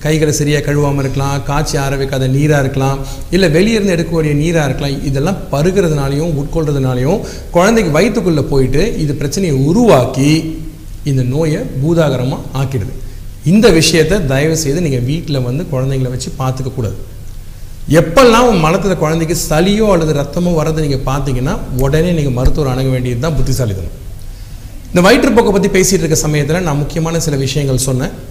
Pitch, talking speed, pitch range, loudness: 145 Hz, 135 wpm, 130-165 Hz, -13 LUFS